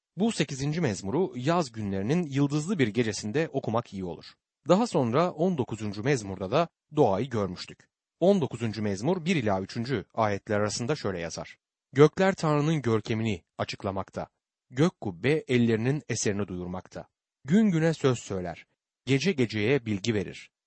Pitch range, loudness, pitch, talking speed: 105-155 Hz, -28 LUFS, 125 Hz, 130 wpm